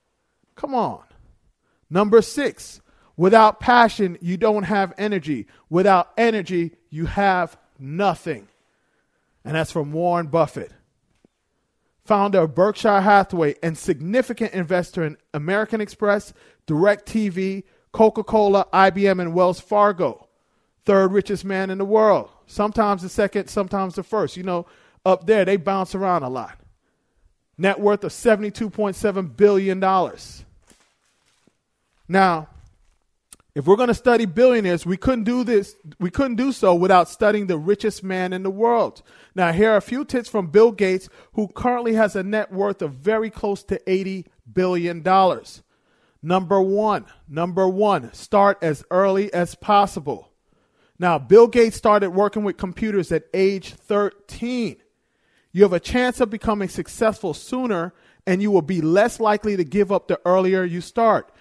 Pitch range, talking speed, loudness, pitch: 180-215 Hz, 145 wpm, -20 LUFS, 195 Hz